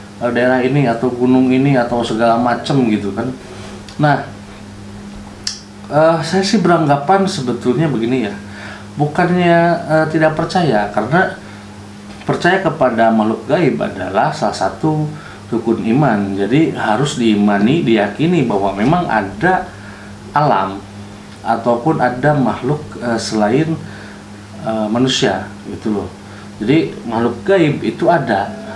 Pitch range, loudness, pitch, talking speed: 105-145 Hz, -15 LUFS, 115 Hz, 115 wpm